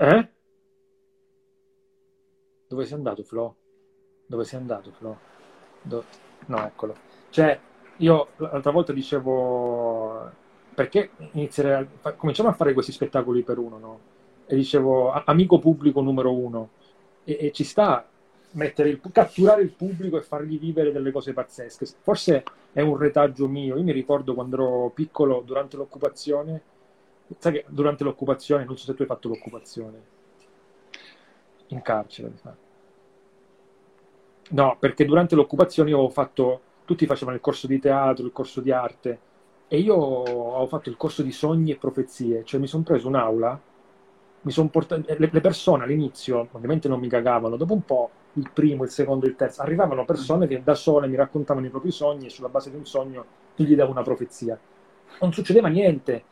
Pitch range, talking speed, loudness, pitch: 130-160 Hz, 160 wpm, -23 LUFS, 145 Hz